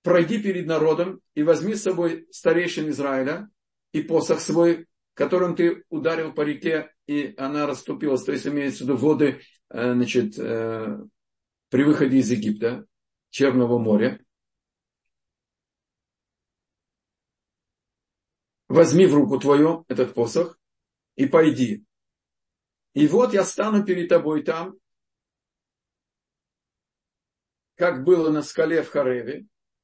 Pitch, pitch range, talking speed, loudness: 155 Hz, 135-175 Hz, 110 wpm, -22 LUFS